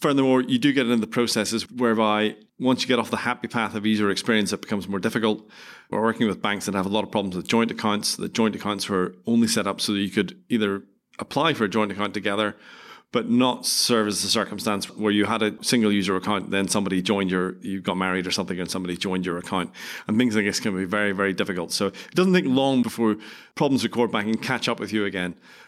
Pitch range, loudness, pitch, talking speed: 100-115 Hz, -23 LUFS, 105 Hz, 245 wpm